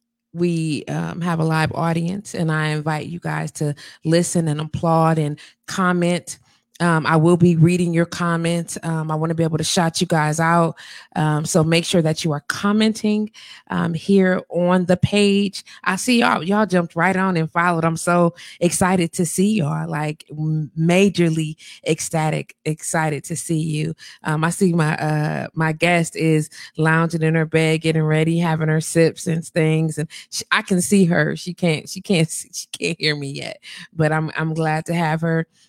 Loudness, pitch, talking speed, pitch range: -19 LUFS, 165 Hz, 190 wpm, 155-175 Hz